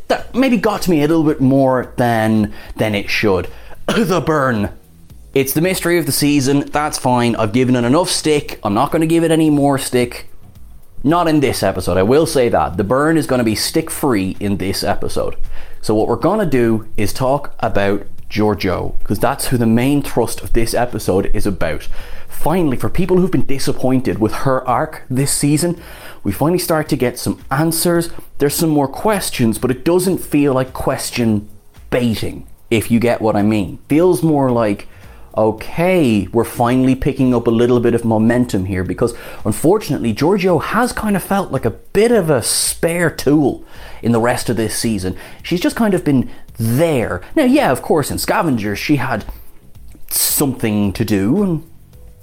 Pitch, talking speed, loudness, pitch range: 125 Hz, 185 wpm, -16 LUFS, 110-155 Hz